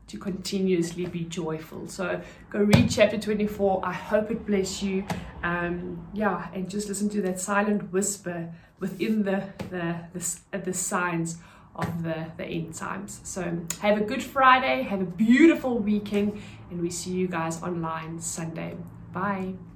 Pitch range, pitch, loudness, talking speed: 170-205 Hz, 185 Hz, -27 LUFS, 155 wpm